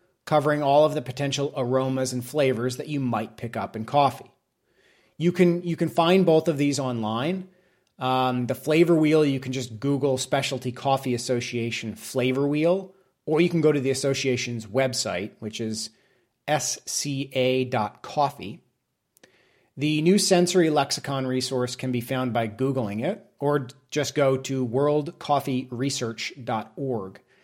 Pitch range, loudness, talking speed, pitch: 125-150 Hz, -25 LUFS, 140 wpm, 135 Hz